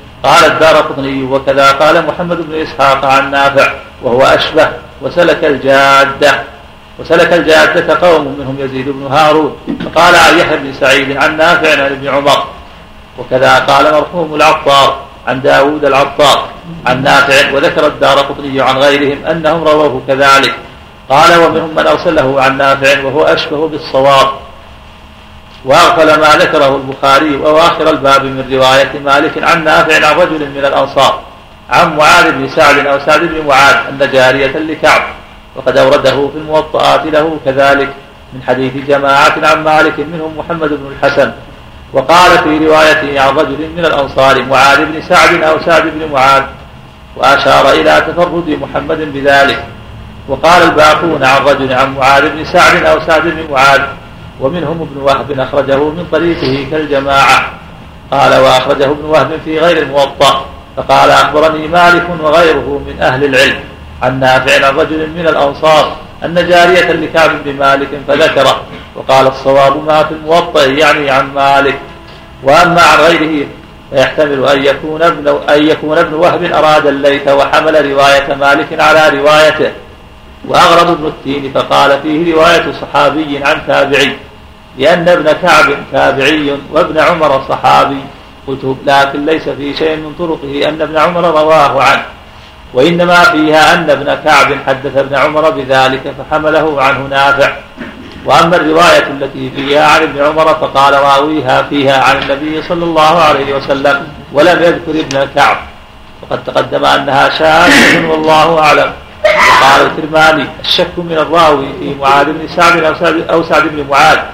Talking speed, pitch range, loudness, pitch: 140 wpm, 135-155 Hz, -8 LUFS, 145 Hz